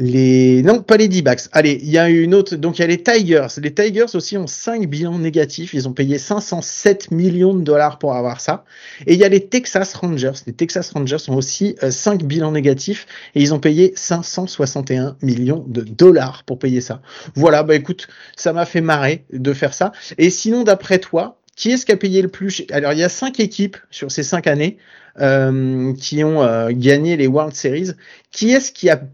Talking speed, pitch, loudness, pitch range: 215 wpm, 160 Hz, -16 LUFS, 140-190 Hz